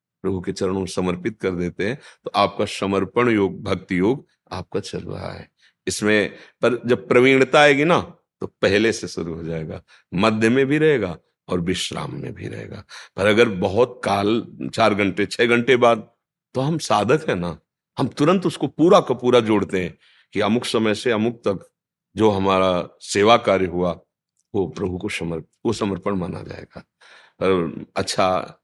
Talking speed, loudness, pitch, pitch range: 170 wpm, -20 LUFS, 100 Hz, 95-120 Hz